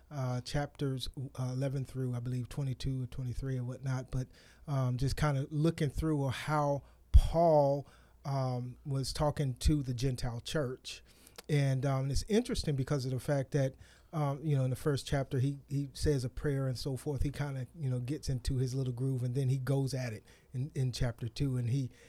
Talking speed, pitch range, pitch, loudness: 200 wpm, 130-145 Hz, 135 Hz, -34 LUFS